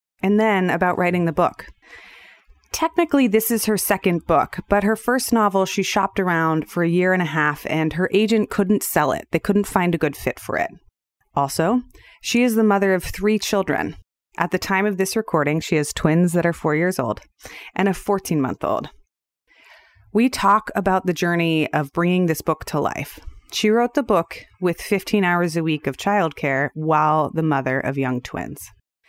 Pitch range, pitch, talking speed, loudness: 160-205 Hz, 180 Hz, 195 wpm, -20 LUFS